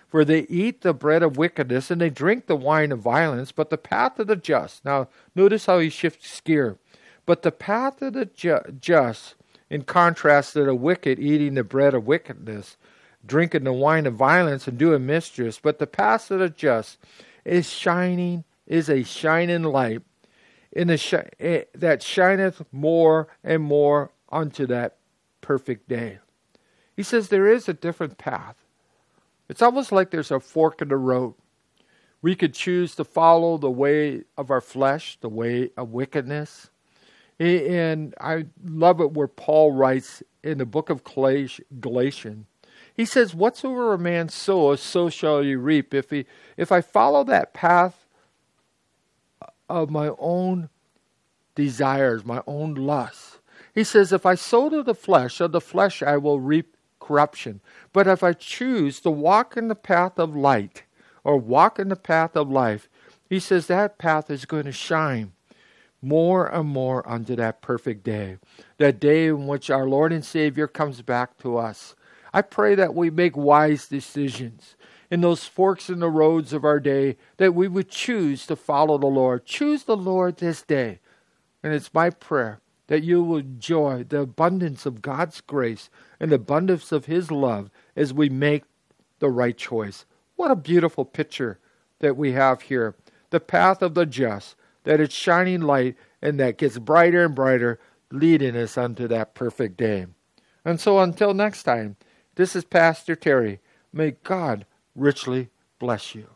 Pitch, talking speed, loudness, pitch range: 155 Hz, 170 wpm, -22 LUFS, 135-175 Hz